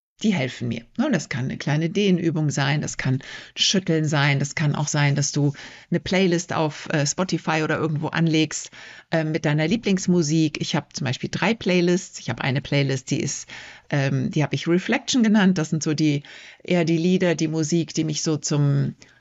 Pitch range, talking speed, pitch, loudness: 145-175 Hz, 195 wpm, 155 Hz, -22 LUFS